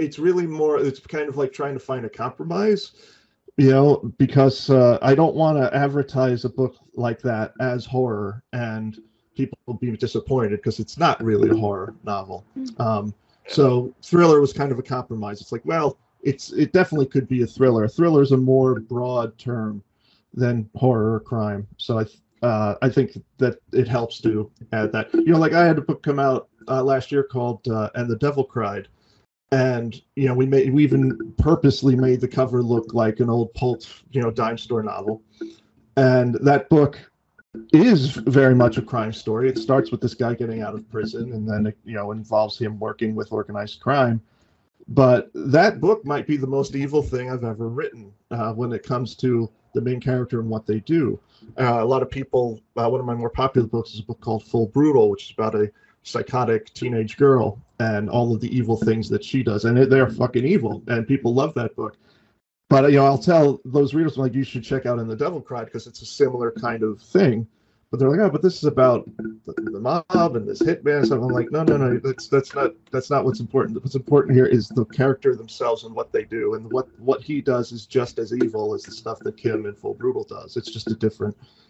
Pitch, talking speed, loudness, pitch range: 125 Hz, 220 wpm, -21 LUFS, 115-135 Hz